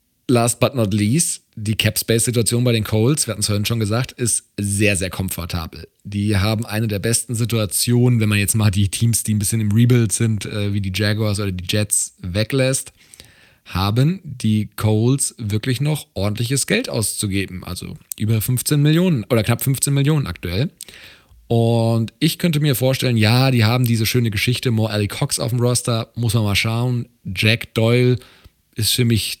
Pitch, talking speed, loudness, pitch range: 115 Hz, 185 wpm, -18 LUFS, 105-125 Hz